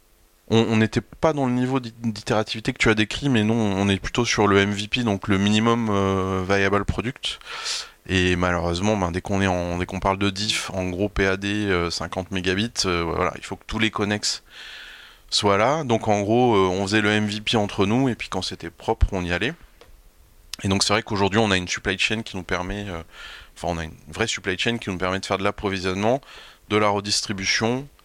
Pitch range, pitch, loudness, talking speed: 95-110 Hz, 100 Hz, -22 LUFS, 220 wpm